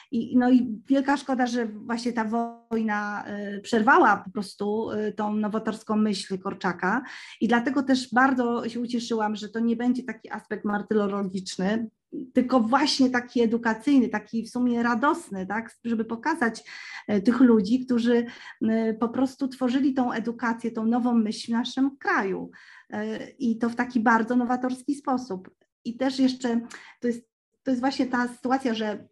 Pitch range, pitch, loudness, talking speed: 220-255 Hz, 235 Hz, -25 LUFS, 150 wpm